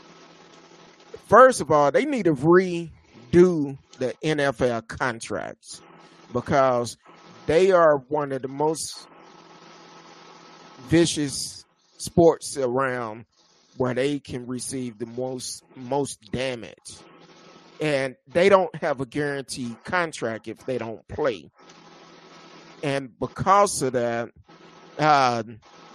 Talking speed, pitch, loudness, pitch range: 100 wpm, 140 Hz, -23 LUFS, 125-165 Hz